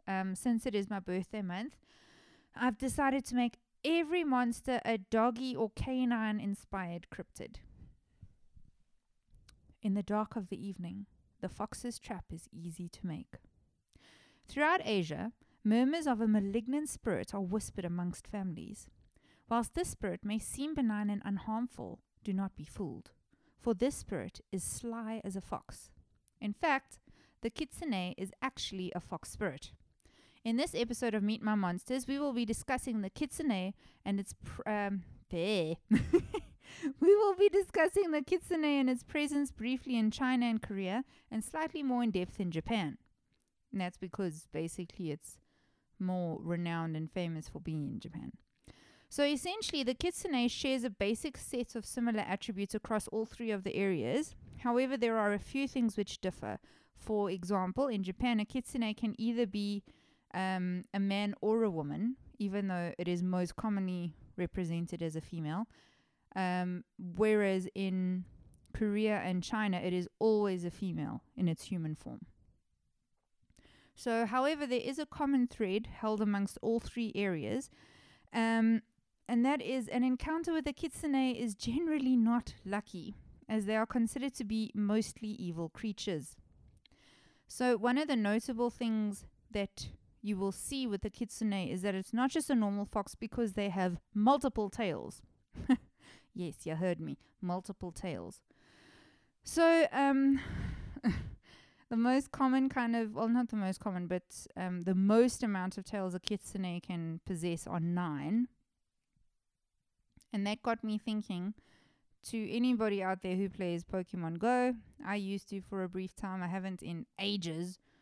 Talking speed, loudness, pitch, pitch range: 155 wpm, -35 LUFS, 215 Hz, 185-245 Hz